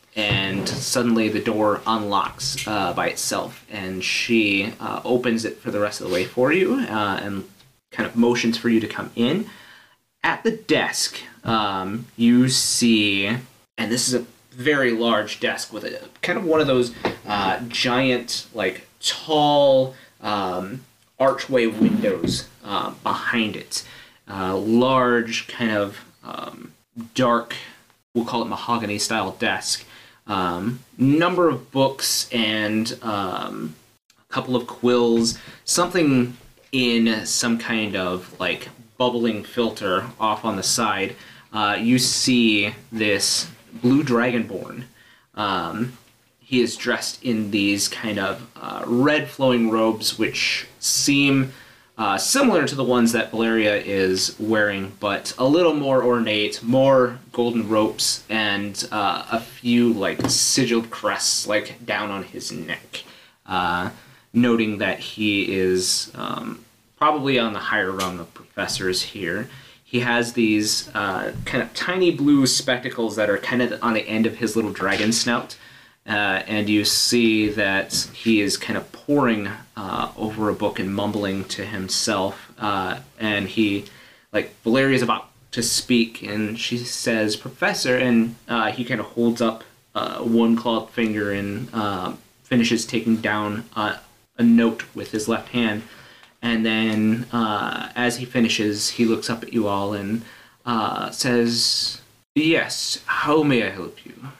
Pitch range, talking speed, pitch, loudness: 105-125 Hz, 145 wpm, 115 Hz, -21 LUFS